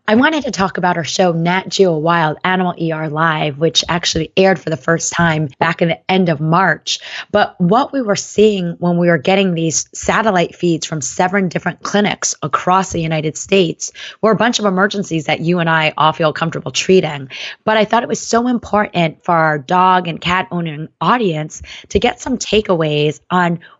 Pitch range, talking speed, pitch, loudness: 160-195 Hz, 195 wpm, 175 Hz, -15 LUFS